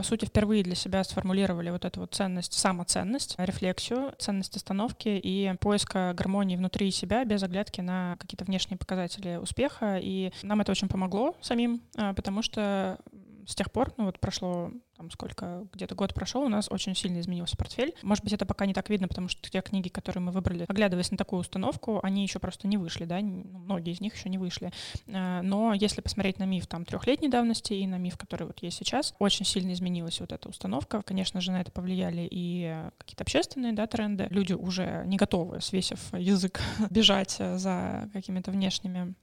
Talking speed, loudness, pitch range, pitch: 190 wpm, -30 LUFS, 185-205 Hz, 195 Hz